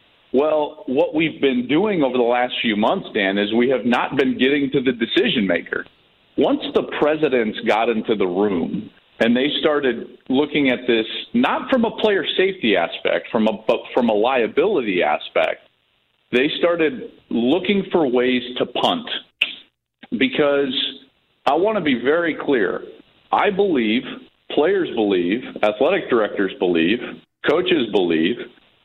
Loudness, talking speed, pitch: -19 LUFS, 145 wpm, 145 Hz